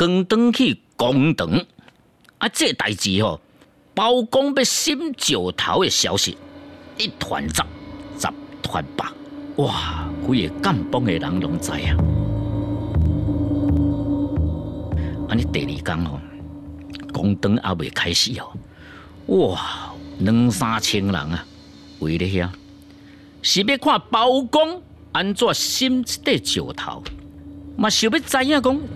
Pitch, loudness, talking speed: 100 Hz, -21 LUFS, 160 characters per minute